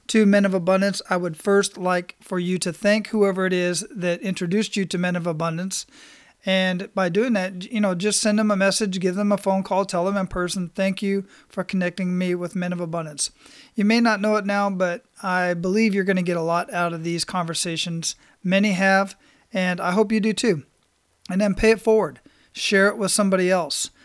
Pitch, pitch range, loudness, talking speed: 190 Hz, 180-205 Hz, -22 LUFS, 220 wpm